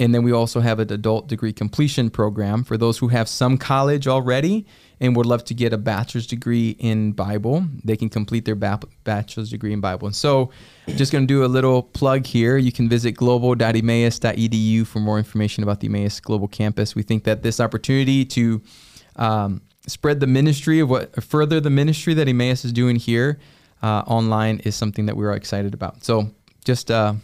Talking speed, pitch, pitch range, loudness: 195 wpm, 115 Hz, 110-130 Hz, -20 LUFS